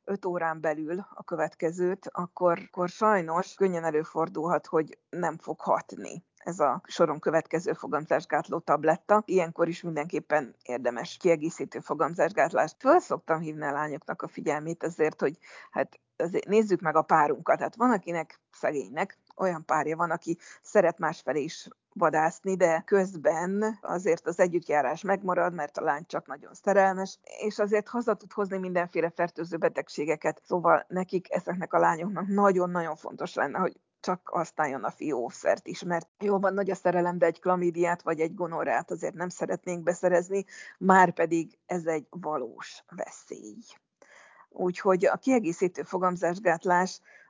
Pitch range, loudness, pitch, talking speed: 160-190 Hz, -28 LUFS, 175 Hz, 145 wpm